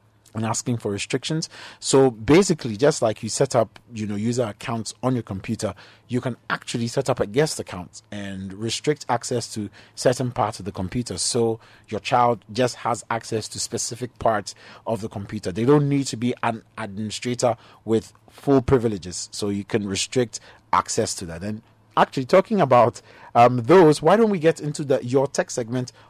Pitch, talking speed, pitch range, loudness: 115 Hz, 180 wpm, 105-130 Hz, -22 LUFS